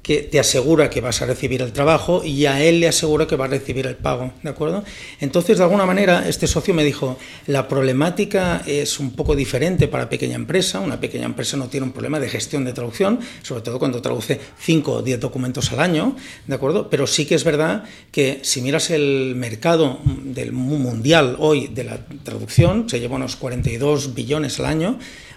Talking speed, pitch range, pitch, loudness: 200 wpm, 130-160 Hz, 140 Hz, -19 LUFS